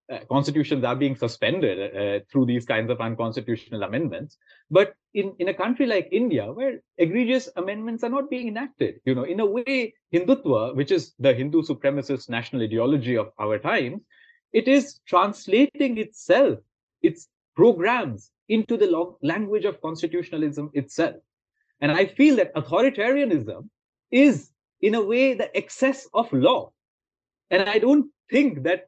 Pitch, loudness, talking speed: 190 Hz, -23 LUFS, 150 wpm